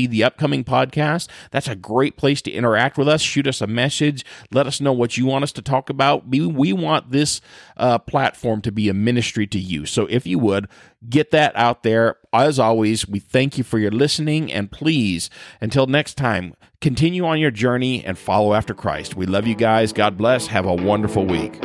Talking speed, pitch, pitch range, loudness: 210 wpm, 125 Hz, 105-140 Hz, -19 LUFS